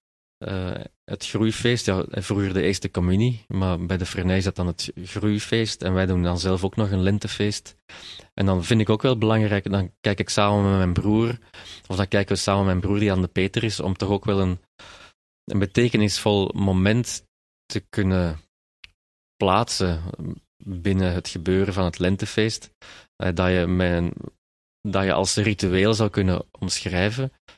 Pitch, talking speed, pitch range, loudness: 95 Hz, 175 wpm, 90-105 Hz, -23 LUFS